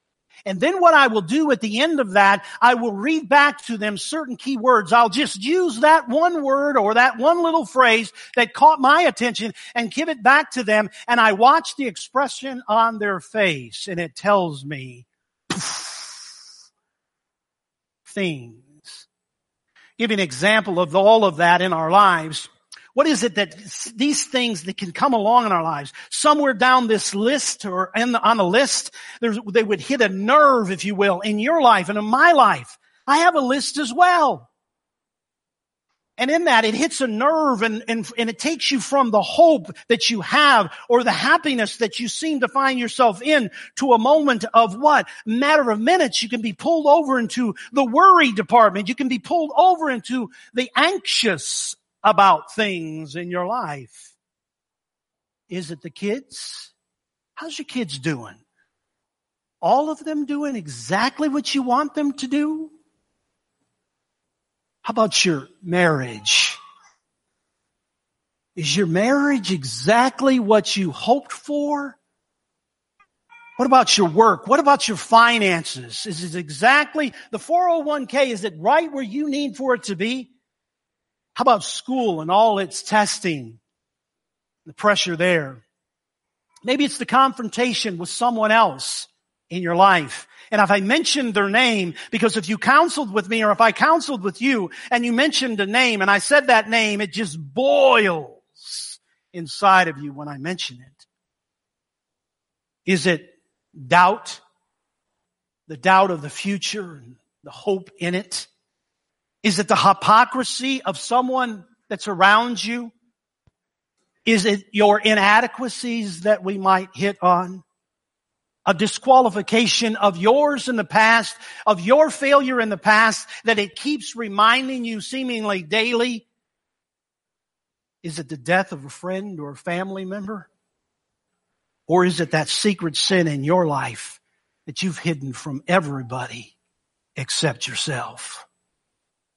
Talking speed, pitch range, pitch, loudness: 155 wpm, 190-265 Hz, 225 Hz, -18 LUFS